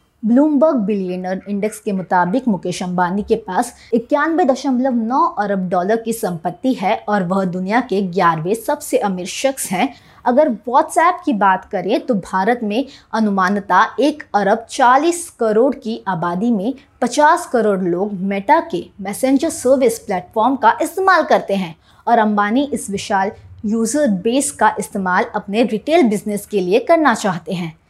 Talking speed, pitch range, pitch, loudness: 150 wpm, 195-265 Hz, 220 Hz, -17 LUFS